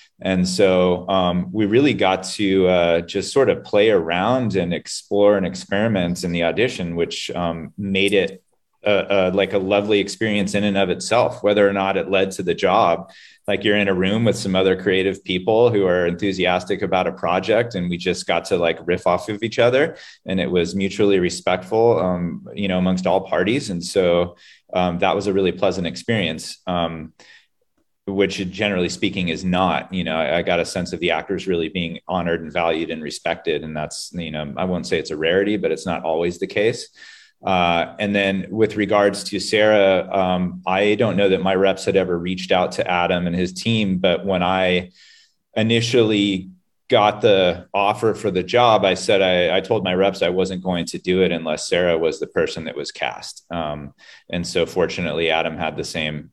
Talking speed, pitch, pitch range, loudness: 200 wpm, 95 Hz, 90-100 Hz, -20 LUFS